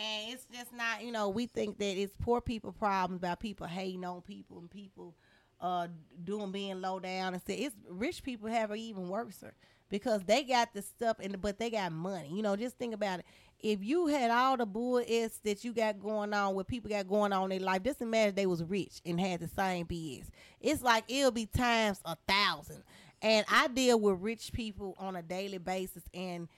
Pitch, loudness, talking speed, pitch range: 205 Hz, -34 LUFS, 225 wpm, 185-230 Hz